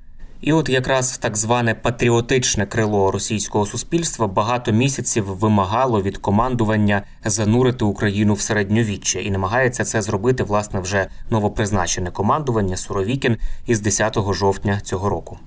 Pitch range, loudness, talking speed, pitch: 100-120 Hz, -19 LUFS, 125 wpm, 110 Hz